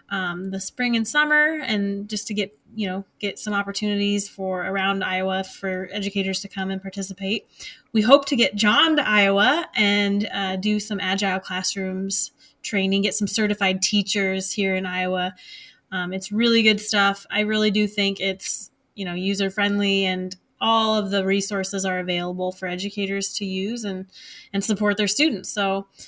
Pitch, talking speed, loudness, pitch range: 200 Hz, 175 wpm, -22 LUFS, 190-210 Hz